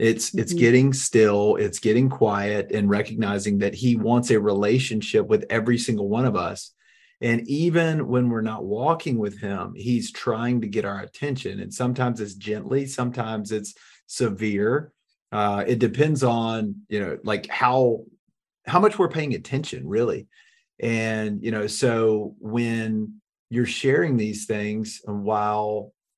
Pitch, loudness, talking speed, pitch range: 115 Hz, -23 LUFS, 150 wpm, 105-125 Hz